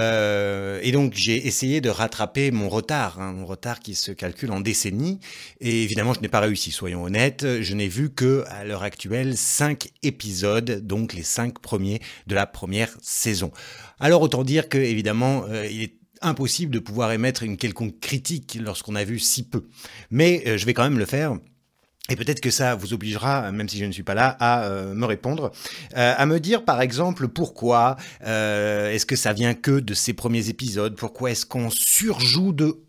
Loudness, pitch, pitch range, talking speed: -23 LUFS, 115 Hz, 105-135 Hz, 190 wpm